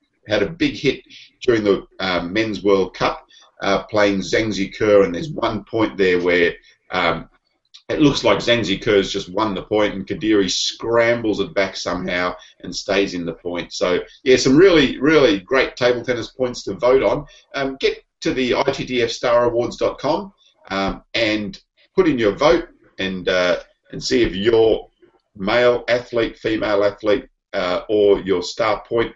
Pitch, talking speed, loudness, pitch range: 105 Hz, 165 wpm, -19 LUFS, 95-120 Hz